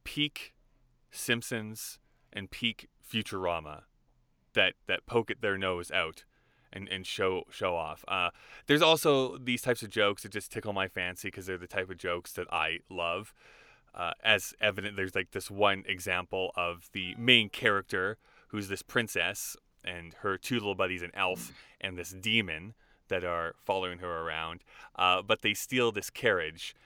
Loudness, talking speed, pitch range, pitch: -31 LUFS, 165 wpm, 90-110 Hz, 95 Hz